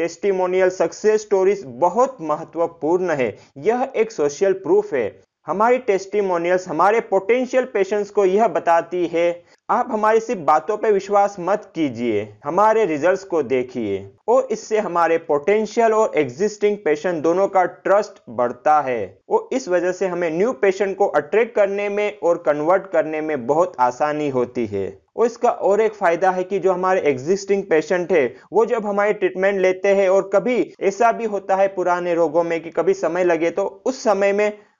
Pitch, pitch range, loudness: 190 Hz, 165-210 Hz, -19 LUFS